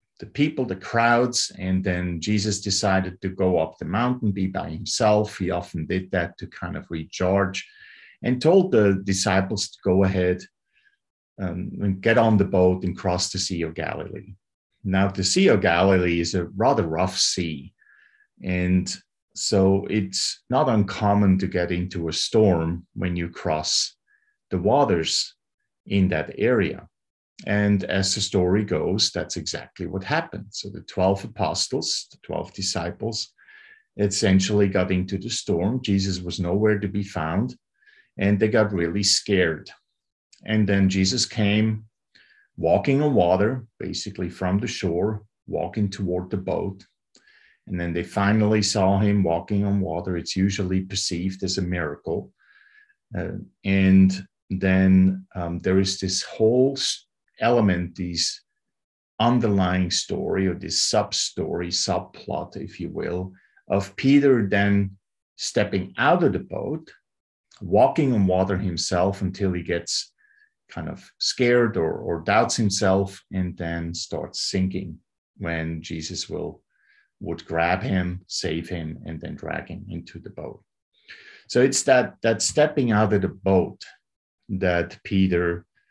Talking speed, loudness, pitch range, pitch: 140 wpm, -23 LUFS, 90-105 Hz, 95 Hz